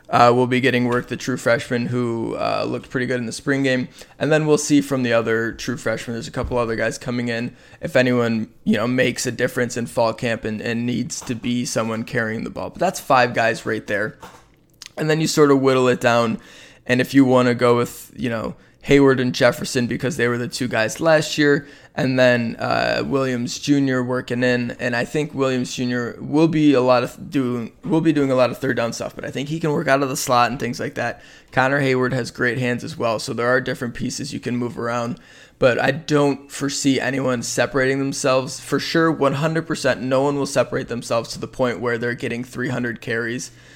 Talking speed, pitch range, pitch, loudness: 230 wpm, 120-135 Hz, 125 Hz, -20 LUFS